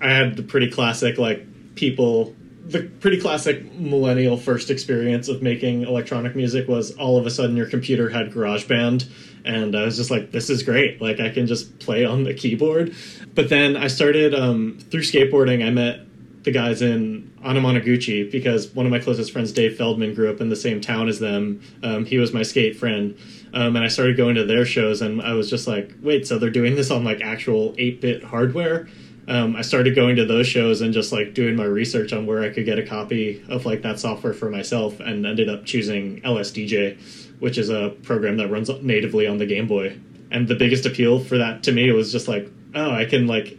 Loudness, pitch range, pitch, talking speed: -21 LUFS, 110-130 Hz, 120 Hz, 220 wpm